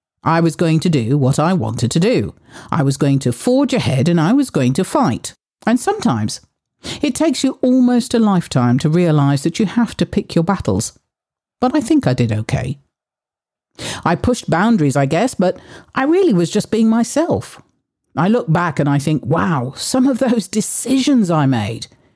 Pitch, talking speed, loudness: 175 Hz, 190 wpm, -16 LUFS